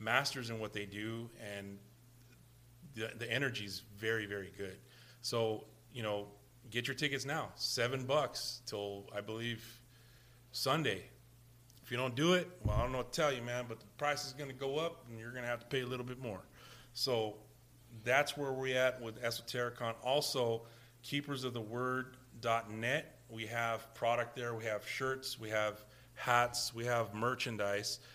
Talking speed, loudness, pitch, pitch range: 170 wpm, -38 LUFS, 120 Hz, 115-130 Hz